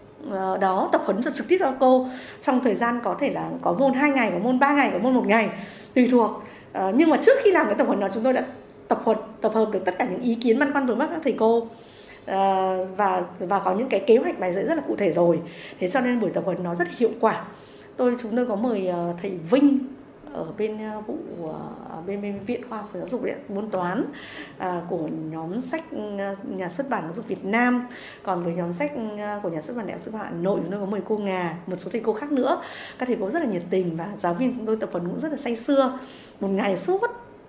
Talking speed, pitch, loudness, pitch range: 260 wpm, 220 Hz, -24 LUFS, 190-255 Hz